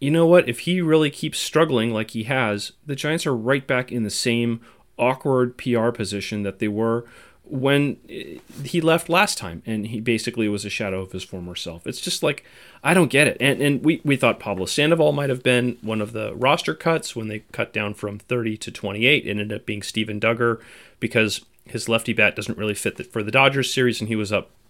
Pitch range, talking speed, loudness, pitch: 105-135 Hz, 225 wpm, -22 LUFS, 115 Hz